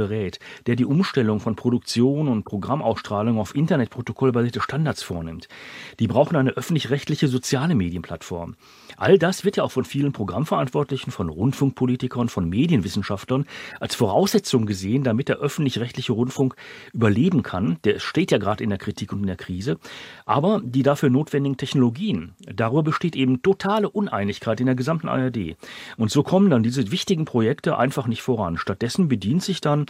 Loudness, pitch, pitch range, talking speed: -22 LUFS, 130 Hz, 115-145 Hz, 155 wpm